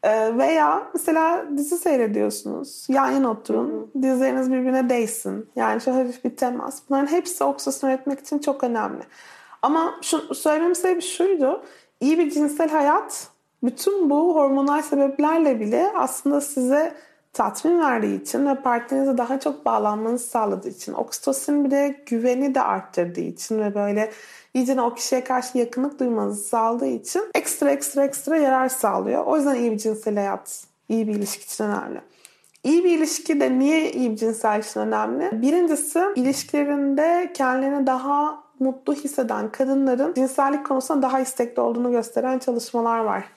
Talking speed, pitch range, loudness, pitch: 145 wpm, 240-300 Hz, -22 LUFS, 270 Hz